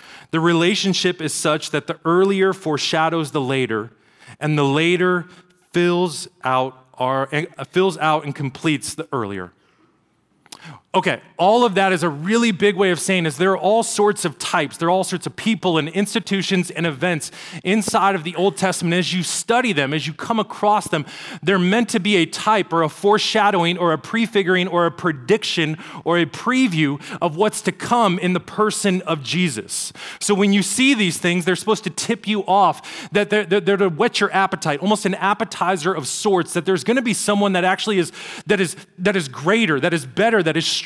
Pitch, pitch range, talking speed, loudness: 180 Hz, 160-205 Hz, 200 wpm, -19 LUFS